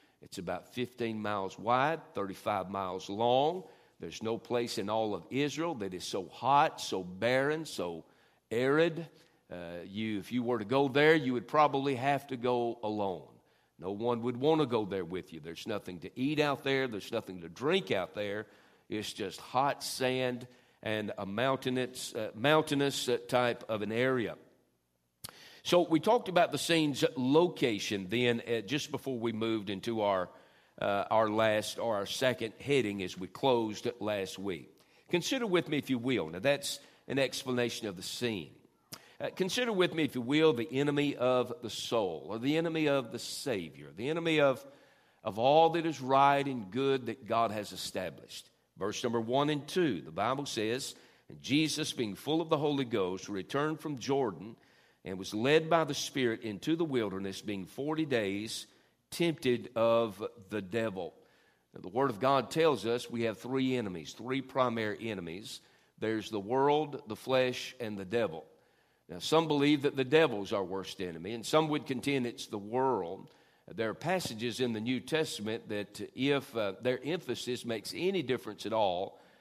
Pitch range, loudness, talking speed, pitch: 105-145 Hz, -32 LUFS, 175 wpm, 125 Hz